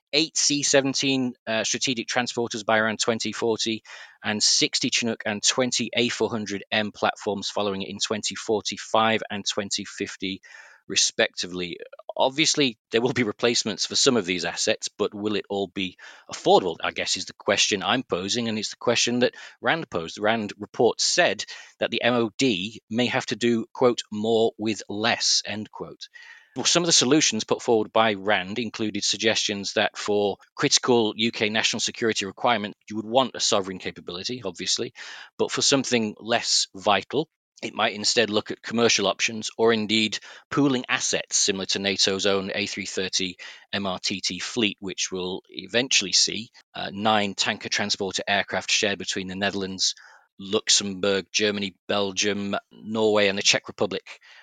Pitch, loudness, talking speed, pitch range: 110 Hz, -23 LUFS, 150 wpm, 100-120 Hz